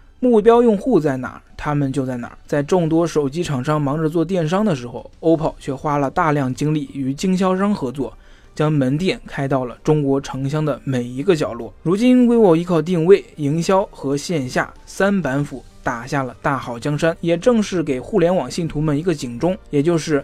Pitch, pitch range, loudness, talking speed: 150 Hz, 135-175 Hz, -19 LUFS, 300 characters per minute